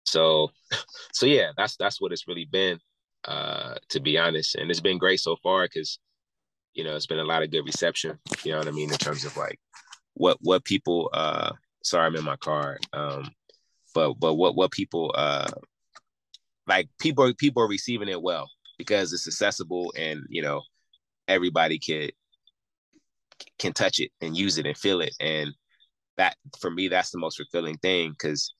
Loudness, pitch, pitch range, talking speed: -26 LUFS, 85 Hz, 75-95 Hz, 185 wpm